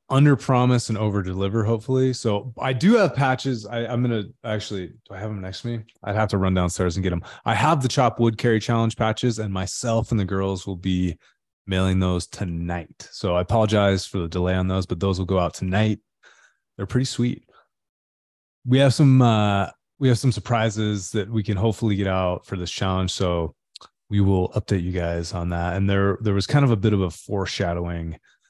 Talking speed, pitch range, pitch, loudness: 215 wpm, 95-115 Hz, 105 Hz, -22 LUFS